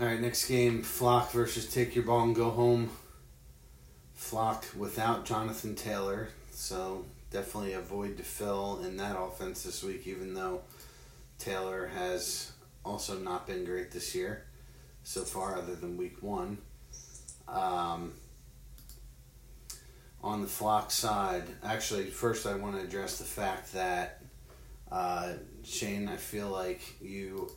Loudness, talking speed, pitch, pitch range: -34 LUFS, 135 wpm, 100 Hz, 90-115 Hz